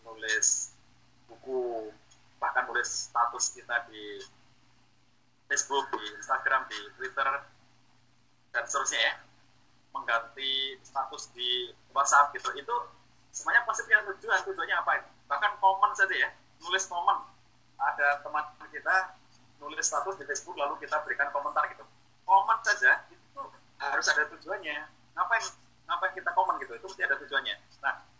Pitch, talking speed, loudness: 180 Hz, 130 wpm, -29 LUFS